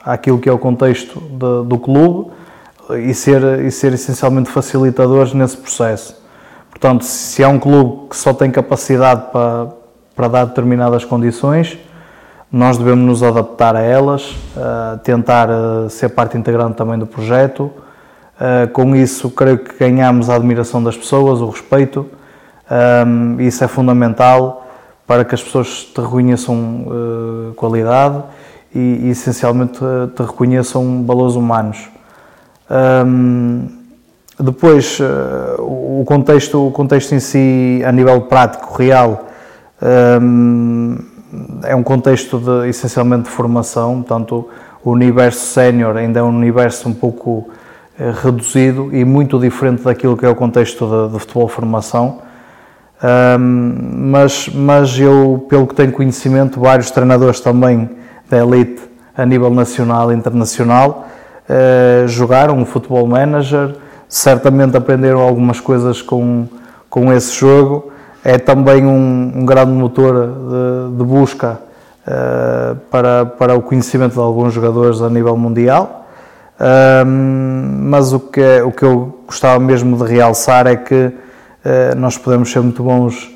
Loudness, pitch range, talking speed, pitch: -12 LUFS, 120-130 Hz, 130 wpm, 125 Hz